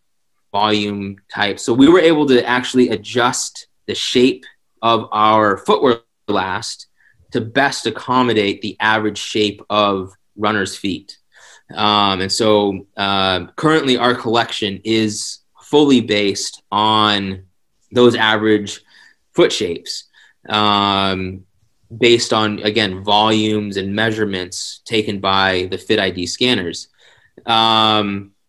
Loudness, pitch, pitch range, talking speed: -16 LUFS, 105 Hz, 100-115 Hz, 110 wpm